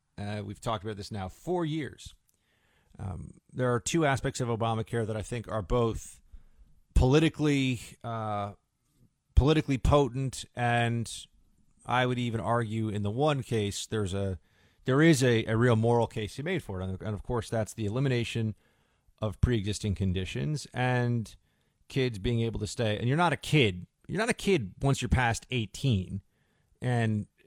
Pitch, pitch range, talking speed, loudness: 115 Hz, 105-130 Hz, 165 wpm, -29 LUFS